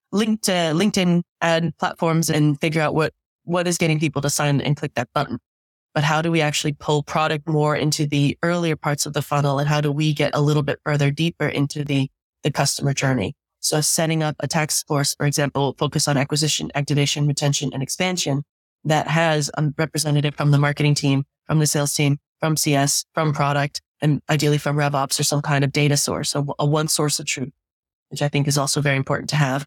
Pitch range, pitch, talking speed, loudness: 145-155 Hz, 150 Hz, 210 wpm, -21 LUFS